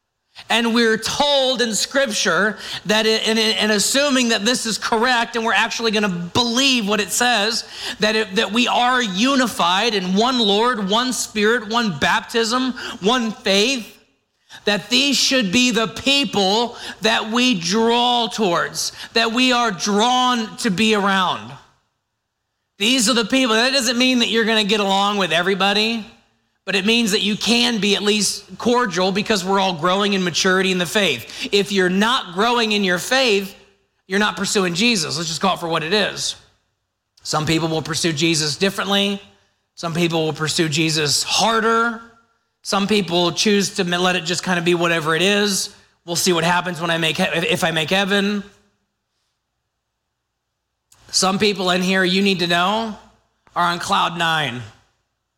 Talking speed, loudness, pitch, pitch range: 165 wpm, -17 LUFS, 205 Hz, 175-230 Hz